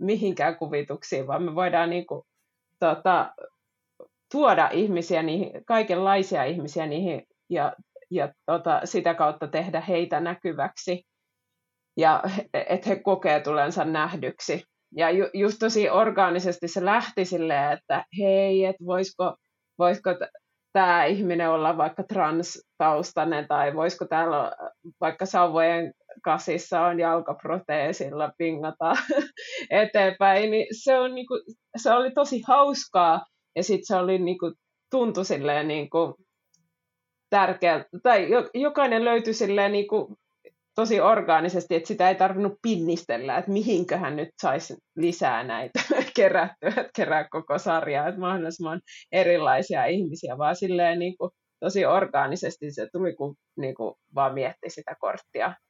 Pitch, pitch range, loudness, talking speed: 180 Hz, 165-205 Hz, -25 LUFS, 120 wpm